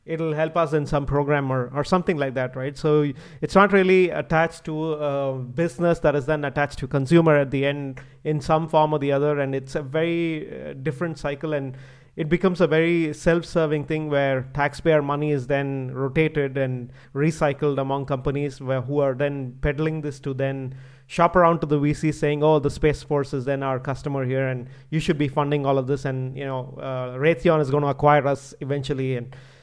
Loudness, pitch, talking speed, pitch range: -23 LUFS, 145 Hz, 205 wpm, 135-155 Hz